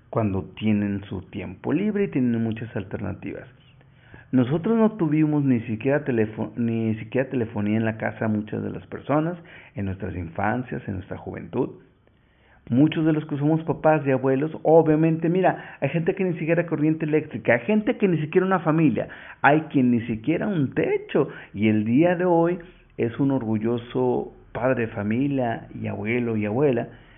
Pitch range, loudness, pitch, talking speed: 110-155 Hz, -23 LUFS, 130 Hz, 170 wpm